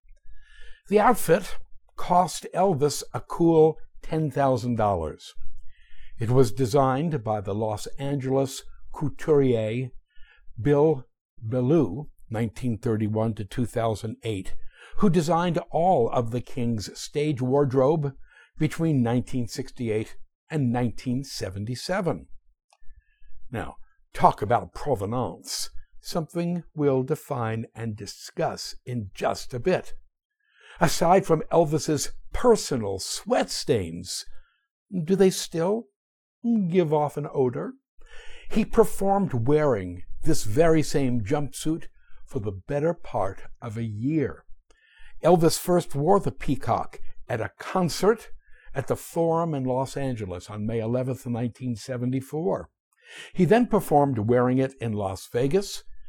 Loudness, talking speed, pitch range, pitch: -25 LUFS, 105 wpm, 120-170 Hz, 140 Hz